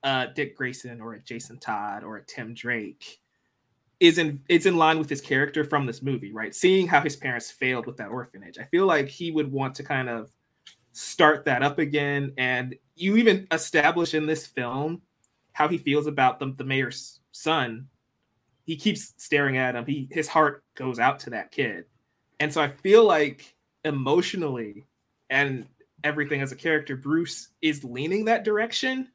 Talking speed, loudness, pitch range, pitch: 180 wpm, -25 LUFS, 130-160 Hz, 145 Hz